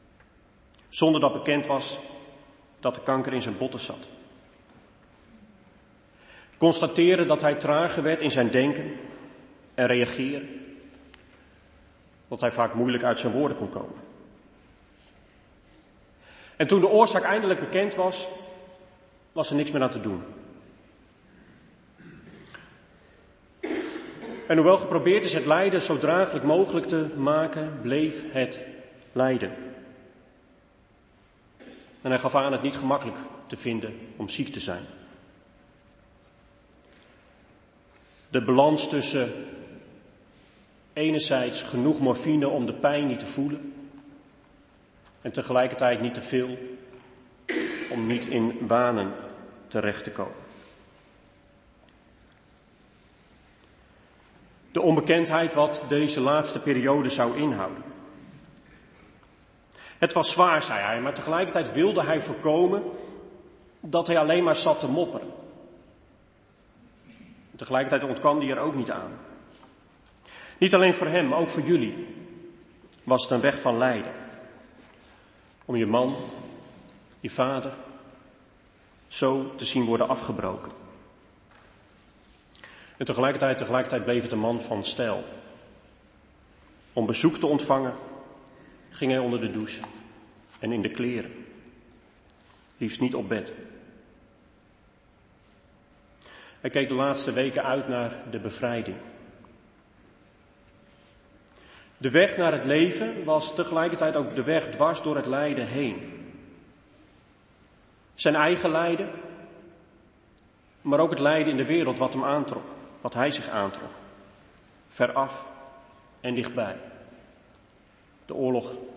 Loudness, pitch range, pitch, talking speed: -25 LUFS, 120-155 Hz, 130 Hz, 115 wpm